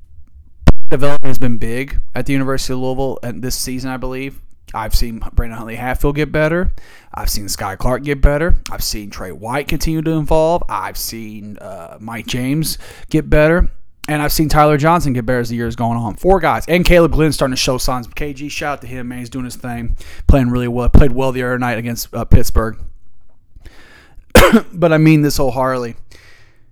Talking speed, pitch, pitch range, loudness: 200 wpm, 125 Hz, 115-145 Hz, -17 LUFS